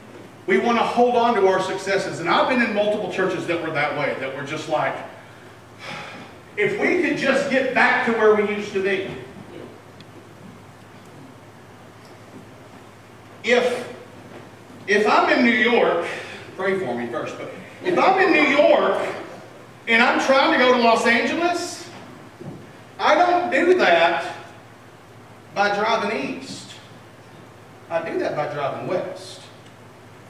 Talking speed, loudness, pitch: 140 wpm, -19 LUFS, 195 Hz